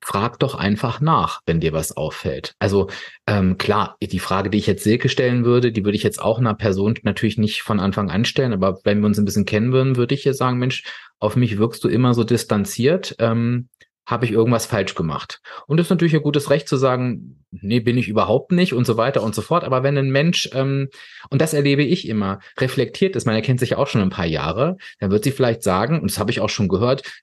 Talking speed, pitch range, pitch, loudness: 245 wpm, 105-135 Hz, 120 Hz, -19 LUFS